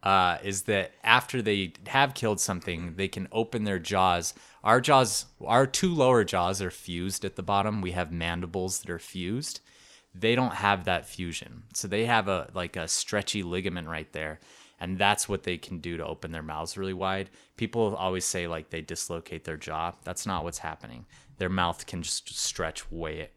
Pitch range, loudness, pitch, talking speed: 85-105 Hz, -28 LUFS, 95 Hz, 195 wpm